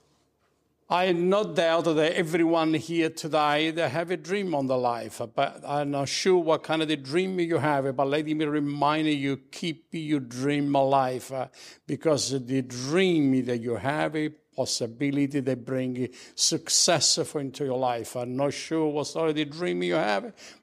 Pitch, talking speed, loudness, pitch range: 145 Hz, 165 wpm, -26 LUFS, 135-160 Hz